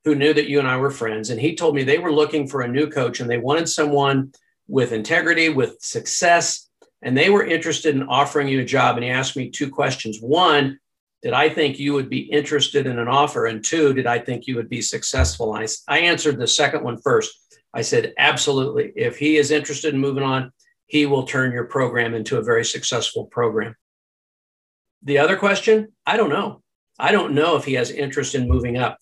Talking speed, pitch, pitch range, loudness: 215 wpm, 145 Hz, 130-160 Hz, -19 LUFS